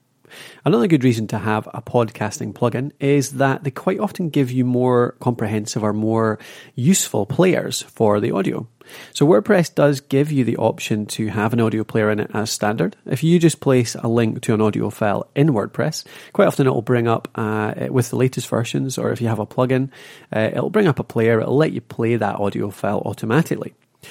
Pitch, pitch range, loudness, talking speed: 120 Hz, 110-140 Hz, -19 LUFS, 205 wpm